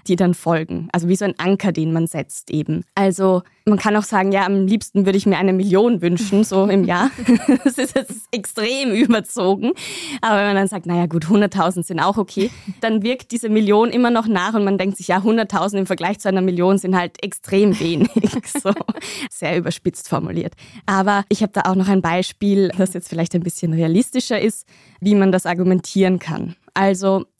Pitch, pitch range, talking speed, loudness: 195 Hz, 180-215 Hz, 200 wpm, -18 LUFS